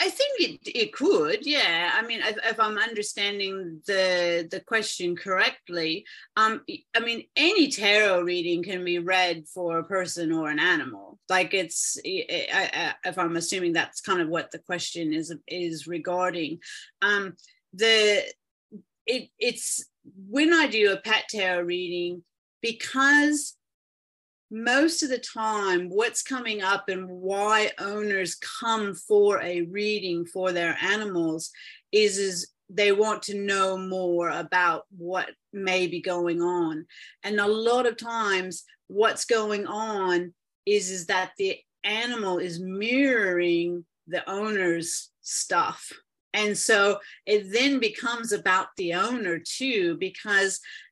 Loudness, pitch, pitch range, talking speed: -25 LUFS, 200 Hz, 180-225 Hz, 135 wpm